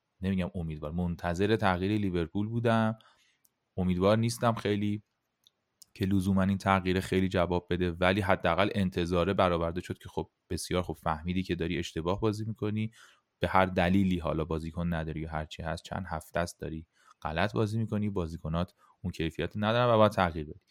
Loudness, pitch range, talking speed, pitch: -30 LUFS, 85-100 Hz, 160 wpm, 95 Hz